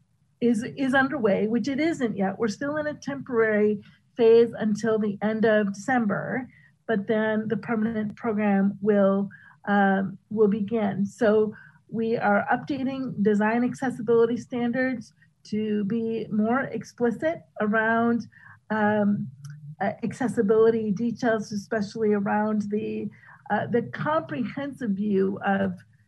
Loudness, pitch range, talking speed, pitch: -25 LUFS, 205-235 Hz, 115 wpm, 215 Hz